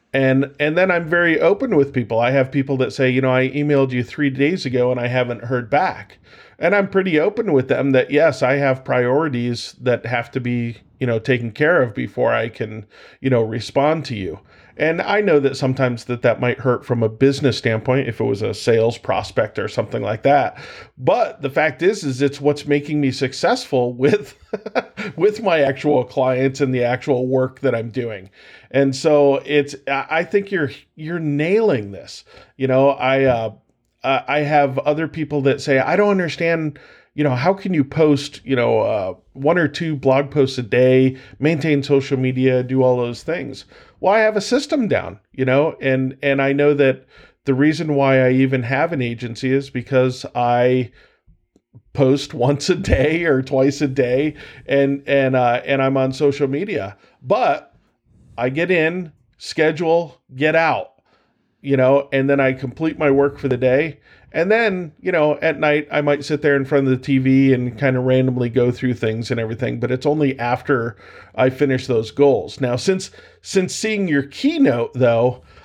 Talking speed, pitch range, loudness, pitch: 190 wpm, 125-150 Hz, -18 LUFS, 135 Hz